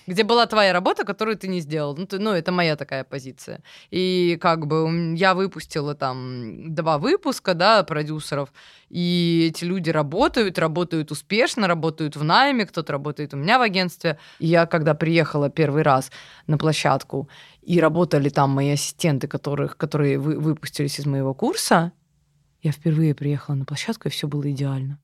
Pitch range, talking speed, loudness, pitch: 145-180 Hz, 165 wpm, -22 LUFS, 160 Hz